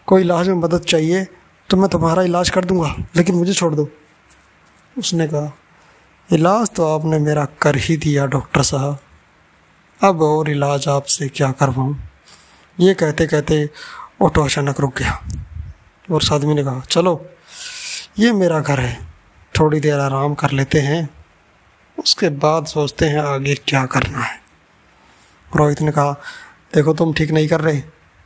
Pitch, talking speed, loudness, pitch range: 150 Hz, 150 wpm, -16 LUFS, 140-165 Hz